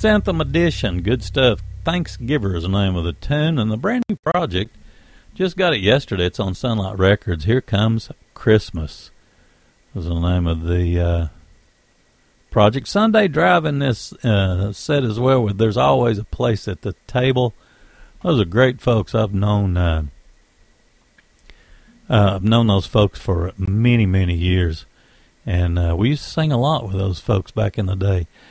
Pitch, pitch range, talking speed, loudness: 105 Hz, 95-130 Hz, 170 wpm, -19 LUFS